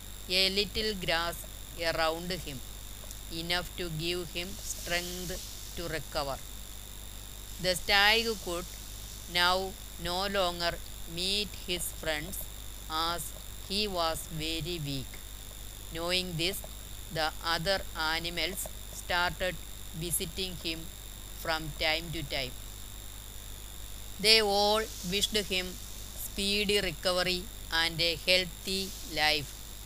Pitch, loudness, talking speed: 165 Hz, -30 LUFS, 95 wpm